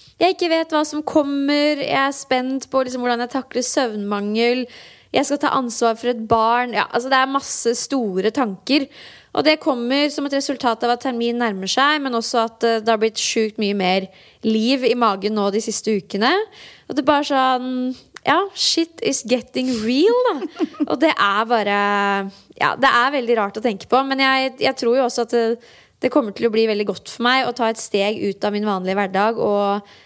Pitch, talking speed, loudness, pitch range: 245 Hz, 210 wpm, -19 LUFS, 220-275 Hz